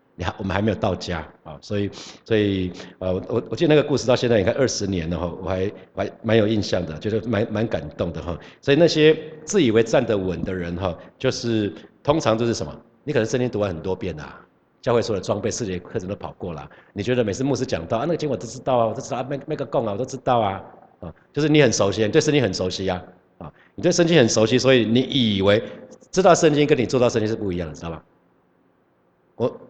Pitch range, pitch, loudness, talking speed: 95-130 Hz, 110 Hz, -21 LUFS, 355 characters per minute